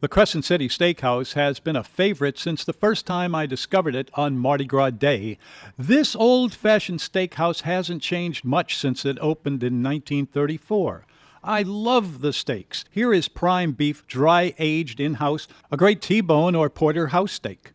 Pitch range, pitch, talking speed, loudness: 140-180 Hz, 160 Hz, 160 wpm, -22 LUFS